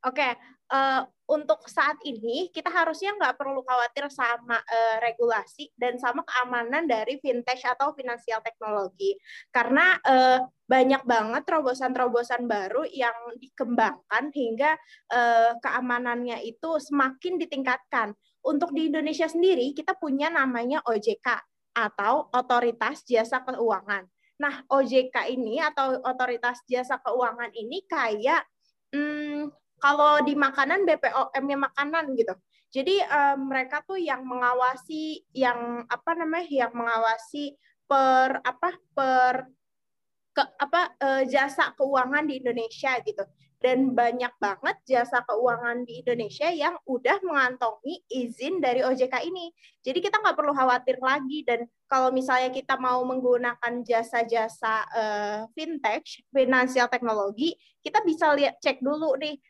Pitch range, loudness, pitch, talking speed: 240-295 Hz, -26 LUFS, 260 Hz, 125 wpm